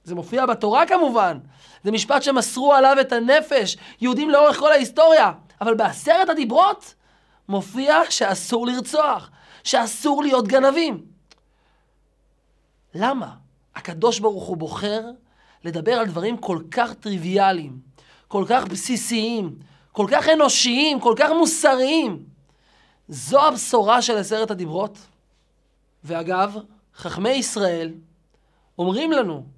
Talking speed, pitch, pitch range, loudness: 110 wpm, 230 Hz, 185-275 Hz, -19 LUFS